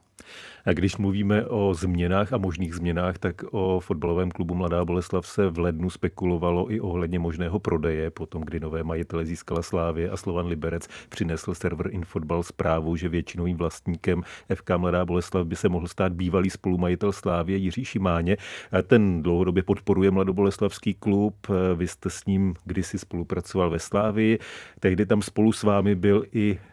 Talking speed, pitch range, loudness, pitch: 155 wpm, 85-100 Hz, -26 LUFS, 90 Hz